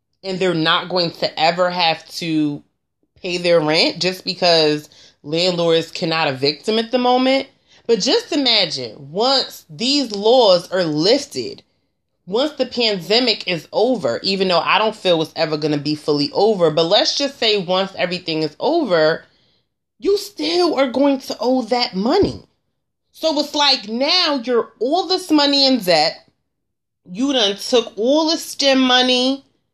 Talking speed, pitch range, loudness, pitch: 155 wpm, 165-270 Hz, -17 LUFS, 215 Hz